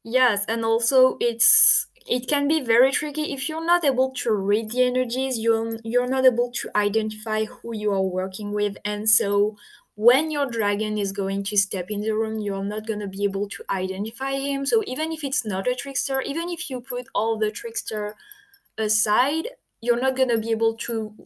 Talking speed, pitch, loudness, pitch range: 200 wpm, 230 Hz, -22 LUFS, 210-265 Hz